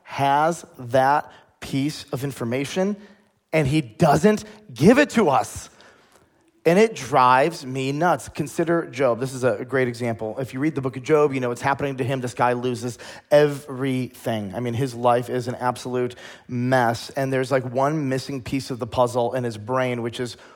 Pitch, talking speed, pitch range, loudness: 135 Hz, 185 wpm, 125-150 Hz, -22 LUFS